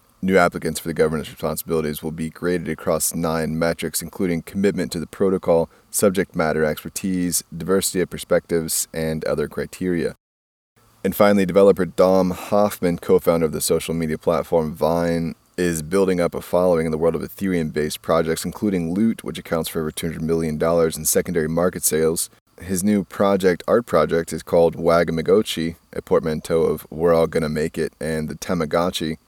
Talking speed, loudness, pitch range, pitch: 170 wpm, -21 LUFS, 80-95 Hz, 85 Hz